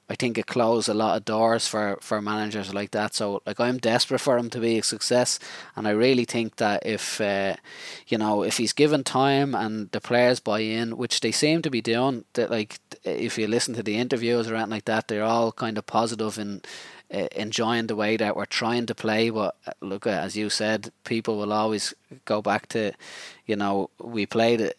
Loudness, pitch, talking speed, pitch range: -25 LUFS, 115 Hz, 220 wpm, 105-120 Hz